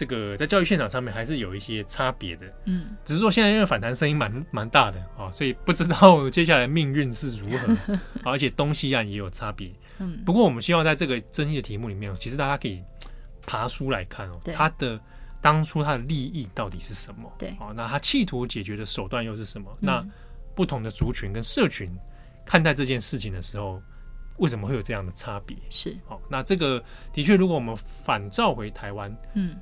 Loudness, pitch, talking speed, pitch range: -24 LUFS, 130 Hz, 315 characters per minute, 105-155 Hz